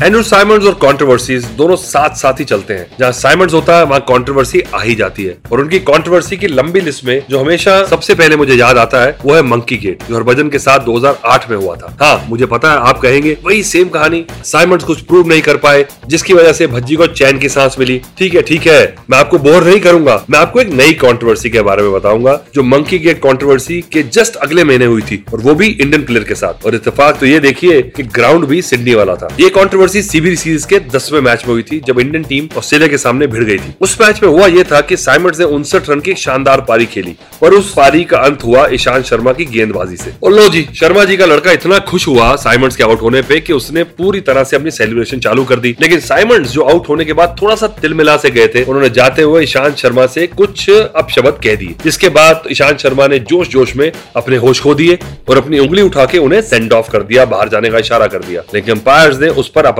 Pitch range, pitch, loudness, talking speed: 130-170 Hz, 145 Hz, -9 LUFS, 240 wpm